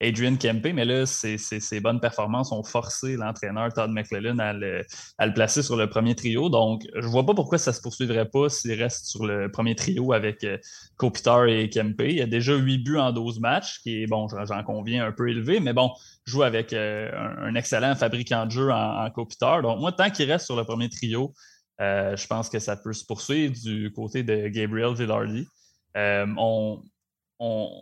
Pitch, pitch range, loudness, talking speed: 115 Hz, 110-125 Hz, -25 LUFS, 215 wpm